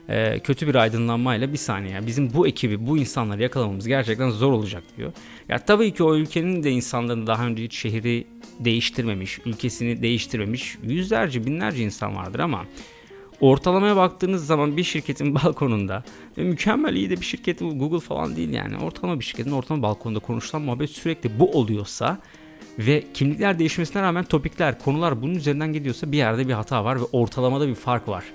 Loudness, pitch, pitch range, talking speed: -23 LUFS, 135 Hz, 115-160 Hz, 165 wpm